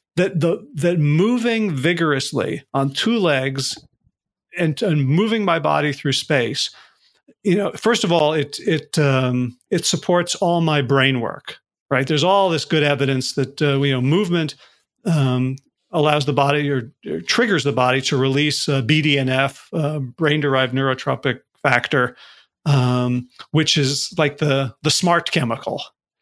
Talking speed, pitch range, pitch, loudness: 155 wpm, 135-170 Hz, 150 Hz, -19 LUFS